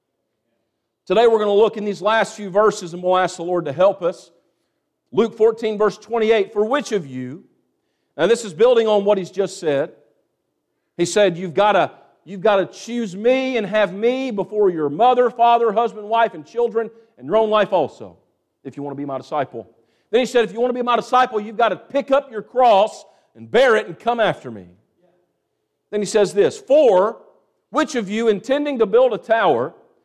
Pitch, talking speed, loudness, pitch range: 215 Hz, 210 wpm, -18 LUFS, 190-240 Hz